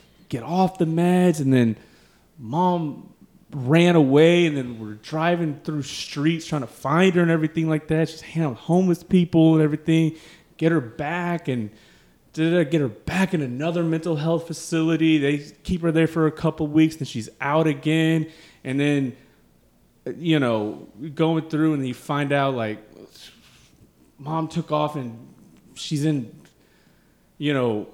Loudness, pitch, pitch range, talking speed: -22 LUFS, 155 Hz, 135-165 Hz, 160 wpm